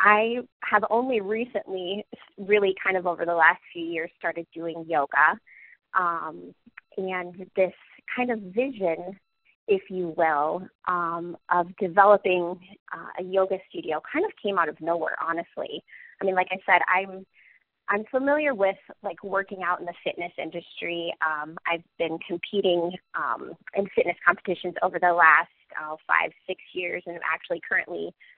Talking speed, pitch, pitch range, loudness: 155 wpm, 185 Hz, 170-200 Hz, -26 LUFS